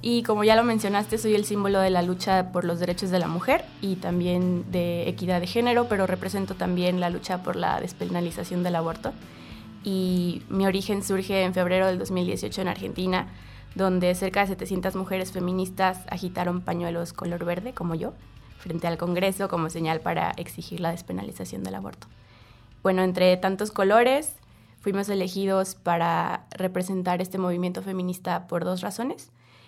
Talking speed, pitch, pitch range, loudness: 160 wpm, 180 Hz, 175-195 Hz, -26 LUFS